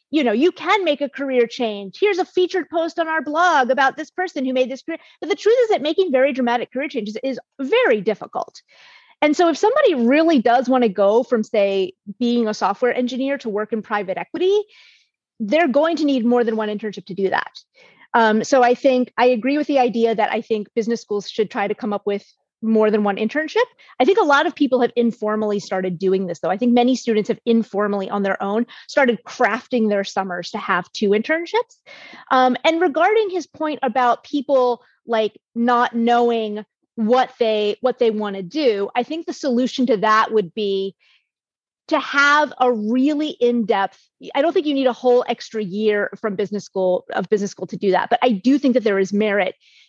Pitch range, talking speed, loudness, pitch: 215-295 Hz, 210 wpm, -19 LUFS, 245 Hz